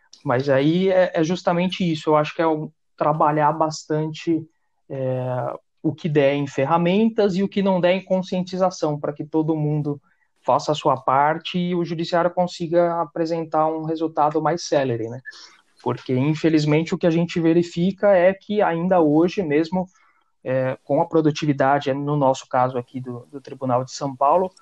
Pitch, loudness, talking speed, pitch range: 160 Hz, -21 LUFS, 170 wpm, 145-175 Hz